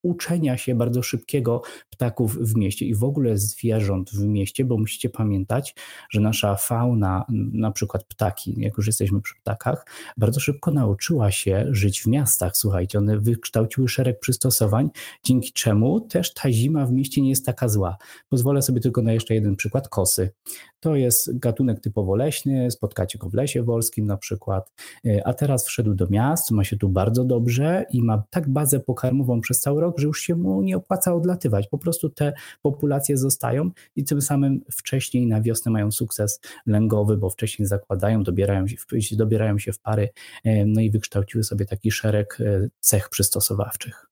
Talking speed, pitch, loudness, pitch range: 170 wpm, 115 Hz, -22 LUFS, 105-130 Hz